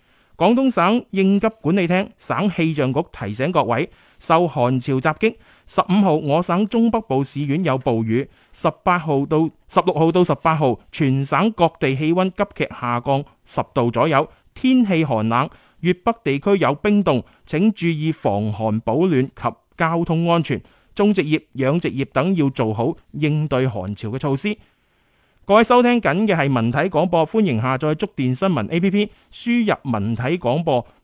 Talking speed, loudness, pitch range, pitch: 245 characters per minute, -19 LUFS, 130-195 Hz, 160 Hz